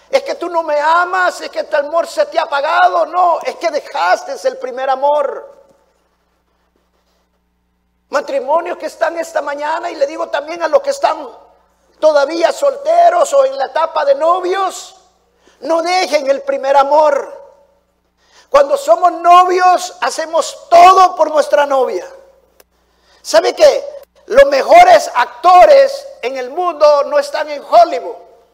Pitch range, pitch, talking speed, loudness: 275-345 Hz, 310 Hz, 140 wpm, -12 LUFS